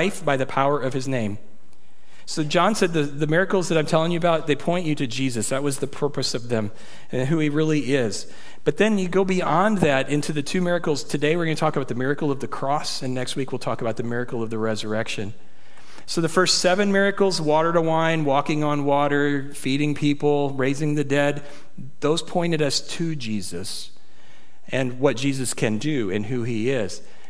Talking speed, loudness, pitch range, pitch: 210 wpm, -23 LUFS, 130-160 Hz, 145 Hz